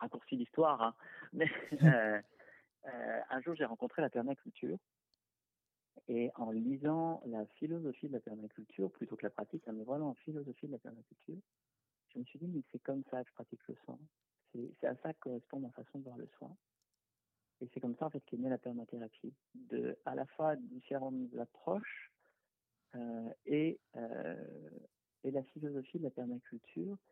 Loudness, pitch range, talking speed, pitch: -40 LUFS, 120-155 Hz, 175 wpm, 130 Hz